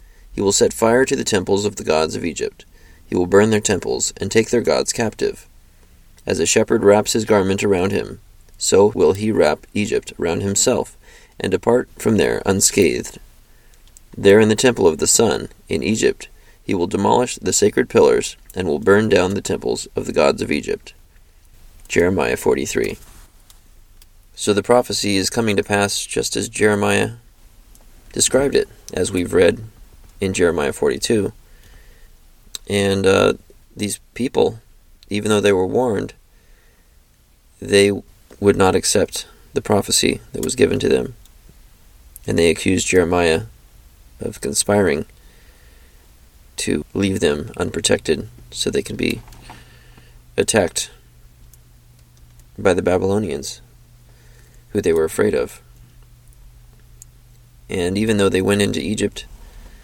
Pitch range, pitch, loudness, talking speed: 80-105 Hz, 95 Hz, -18 LUFS, 140 wpm